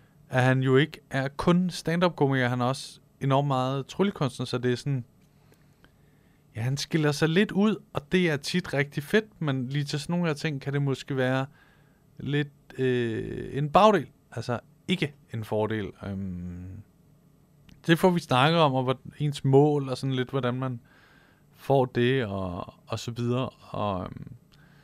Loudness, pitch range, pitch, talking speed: -27 LUFS, 125-155 Hz, 140 Hz, 170 wpm